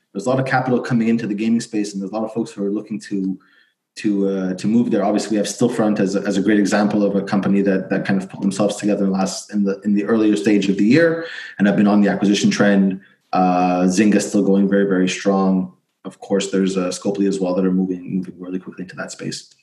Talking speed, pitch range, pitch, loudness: 265 wpm, 95-105 Hz, 100 Hz, -18 LUFS